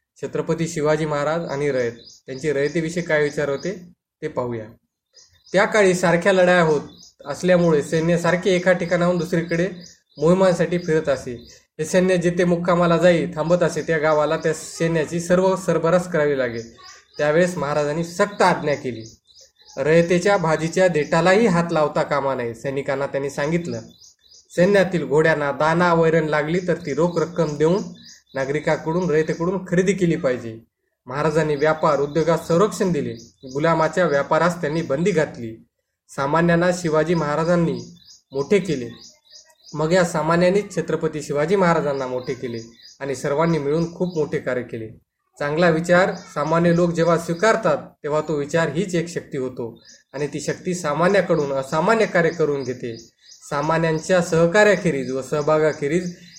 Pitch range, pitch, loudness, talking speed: 145-175 Hz, 160 Hz, -20 LUFS, 135 wpm